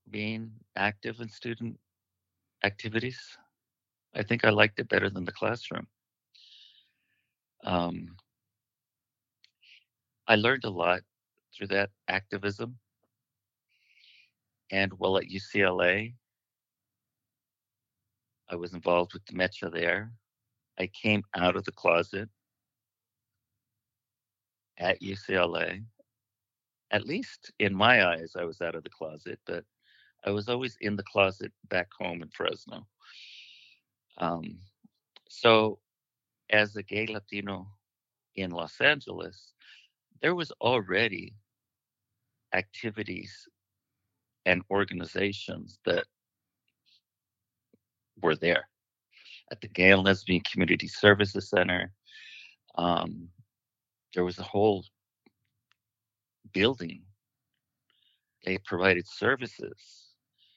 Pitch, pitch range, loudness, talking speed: 105 Hz, 95-115 Hz, -28 LUFS, 95 wpm